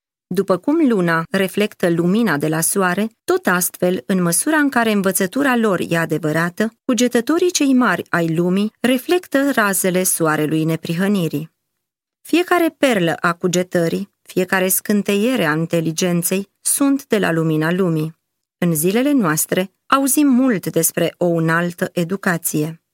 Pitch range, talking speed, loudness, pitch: 170-235 Hz, 130 wpm, -17 LUFS, 185 Hz